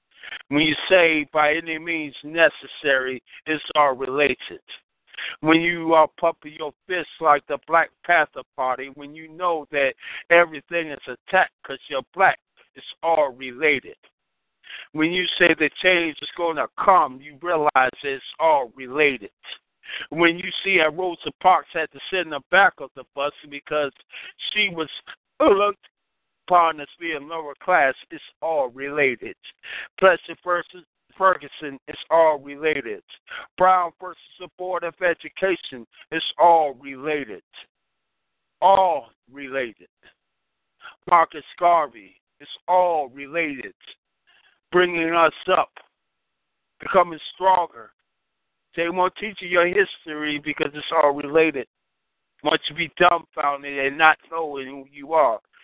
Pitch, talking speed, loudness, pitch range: 160 Hz, 130 wpm, -21 LUFS, 145-175 Hz